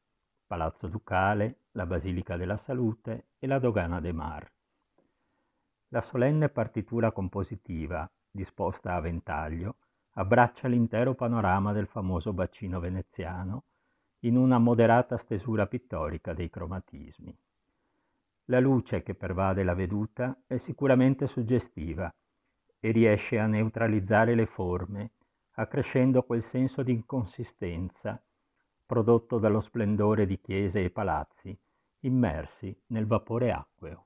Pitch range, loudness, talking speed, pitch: 95-120 Hz, -29 LUFS, 110 wpm, 110 Hz